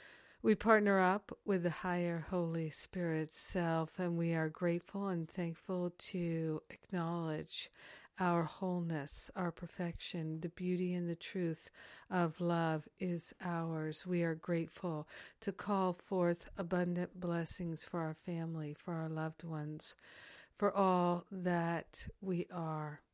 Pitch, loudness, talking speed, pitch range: 175 Hz, -38 LUFS, 130 wpm, 165-180 Hz